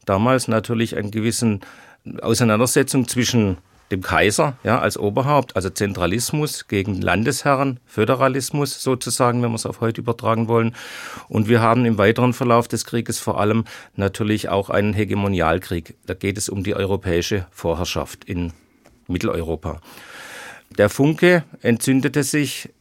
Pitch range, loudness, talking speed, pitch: 100-125 Hz, -20 LUFS, 135 wpm, 115 Hz